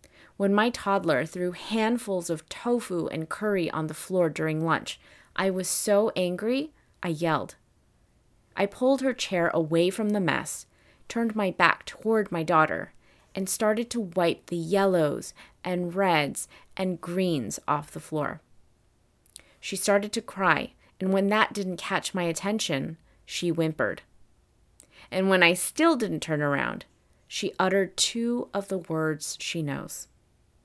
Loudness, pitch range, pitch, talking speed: -27 LUFS, 165-205 Hz, 185 Hz, 145 wpm